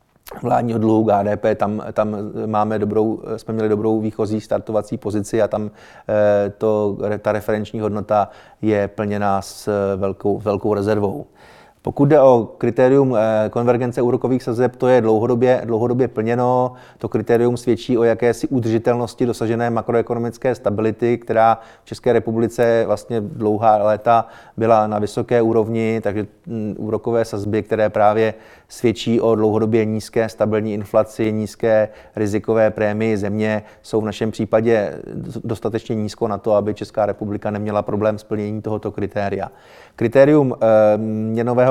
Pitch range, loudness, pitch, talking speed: 105-115 Hz, -19 LUFS, 110 Hz, 130 wpm